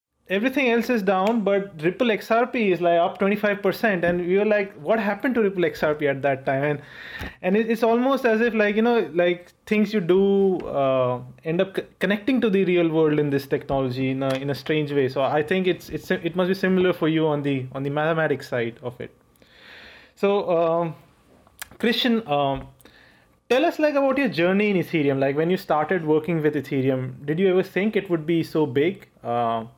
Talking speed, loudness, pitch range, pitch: 210 wpm, -22 LUFS, 145-205 Hz, 175 Hz